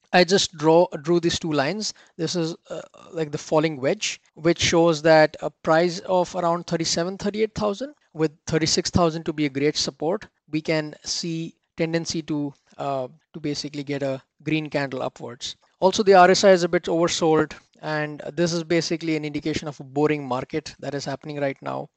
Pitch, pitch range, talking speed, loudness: 160 Hz, 150-175 Hz, 180 wpm, -23 LUFS